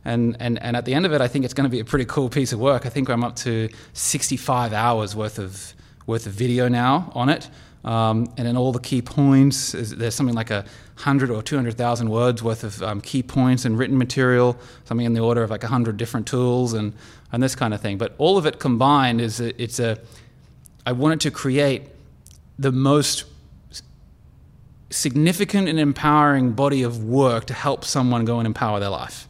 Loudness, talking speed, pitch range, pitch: -21 LUFS, 205 wpm, 115-135 Hz, 125 Hz